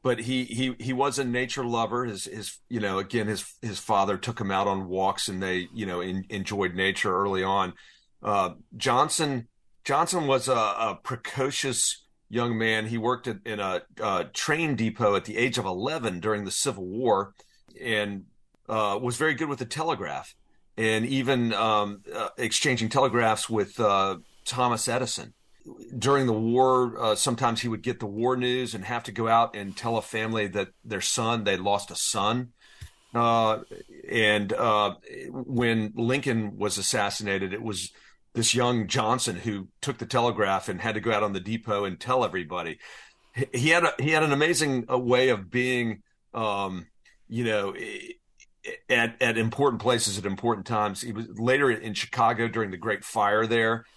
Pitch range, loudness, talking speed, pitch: 105-125 Hz, -26 LUFS, 175 wpm, 115 Hz